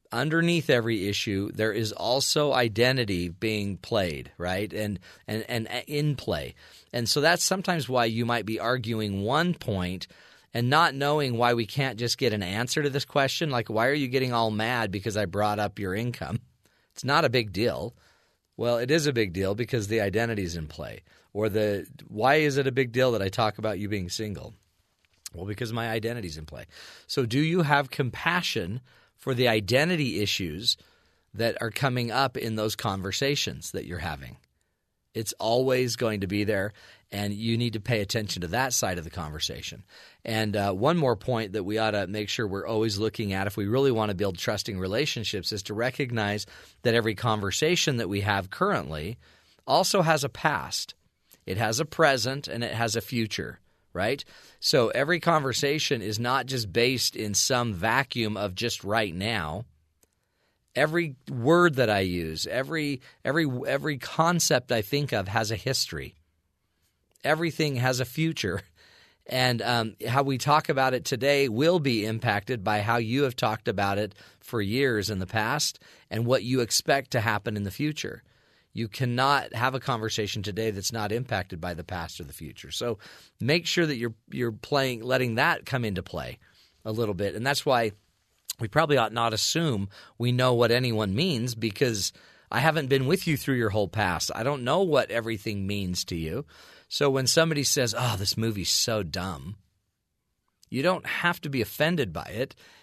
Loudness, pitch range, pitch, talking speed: -27 LUFS, 100-135 Hz, 115 Hz, 185 wpm